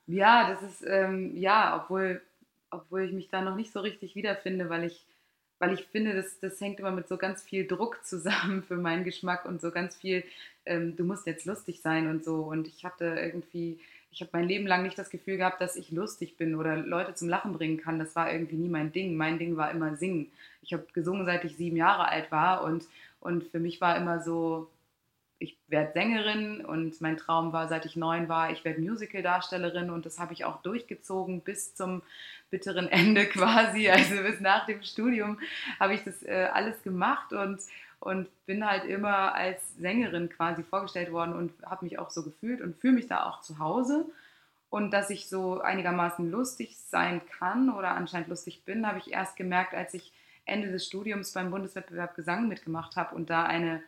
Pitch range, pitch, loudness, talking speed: 170-195 Hz, 180 Hz, -30 LUFS, 205 wpm